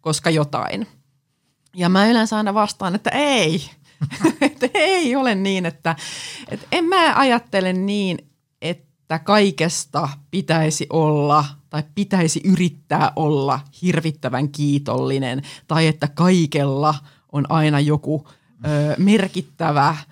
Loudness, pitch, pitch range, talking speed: -19 LUFS, 160 Hz, 145-190 Hz, 110 wpm